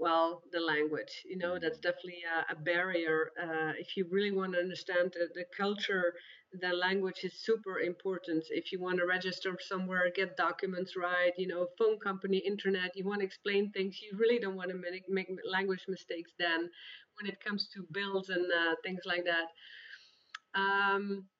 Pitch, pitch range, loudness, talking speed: 185 Hz, 175-195 Hz, -34 LUFS, 175 wpm